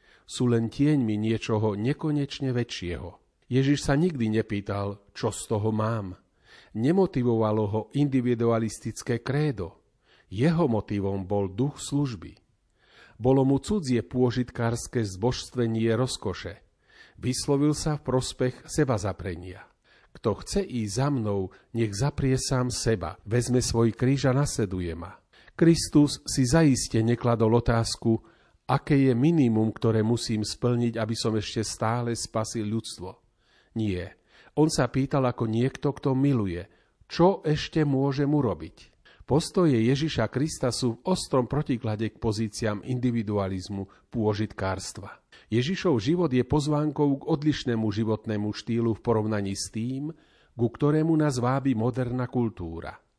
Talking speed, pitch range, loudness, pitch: 120 wpm, 110-135 Hz, -26 LUFS, 120 Hz